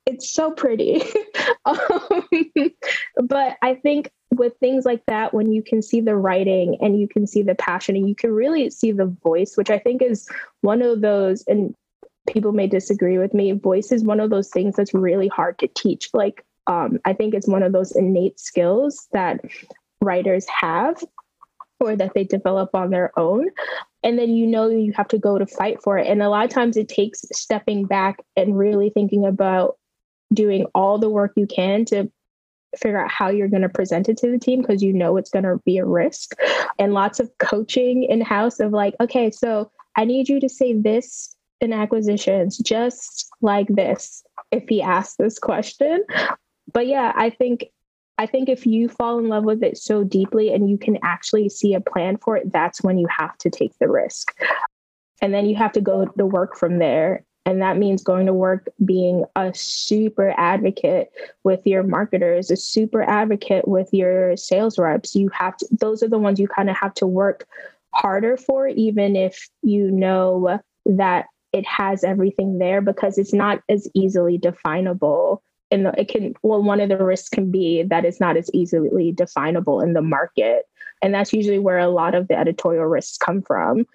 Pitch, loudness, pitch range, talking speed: 205 Hz, -20 LUFS, 190-230 Hz, 195 wpm